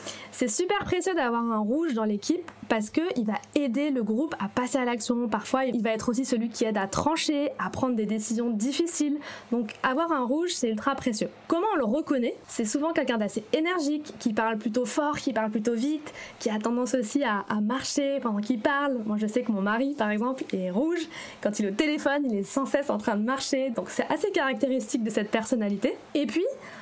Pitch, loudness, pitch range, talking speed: 255 Hz, -27 LUFS, 225-290 Hz, 220 wpm